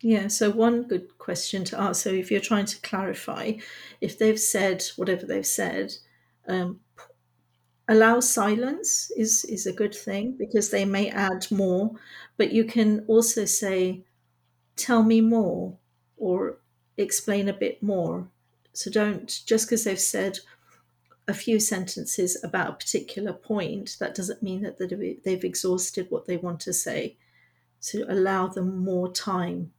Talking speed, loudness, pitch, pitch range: 150 wpm, -25 LUFS, 200 Hz, 185-220 Hz